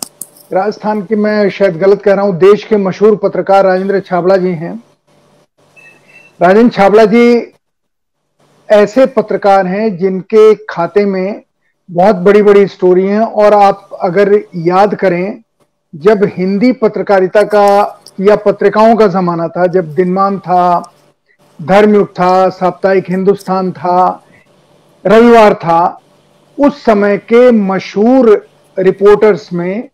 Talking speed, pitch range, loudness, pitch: 120 wpm, 185-210 Hz, -9 LUFS, 195 Hz